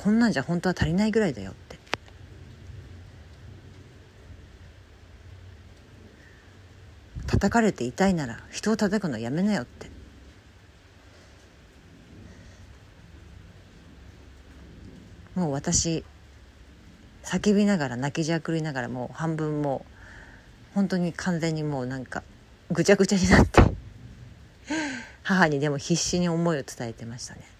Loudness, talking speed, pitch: -25 LUFS, 220 characters per minute, 105 Hz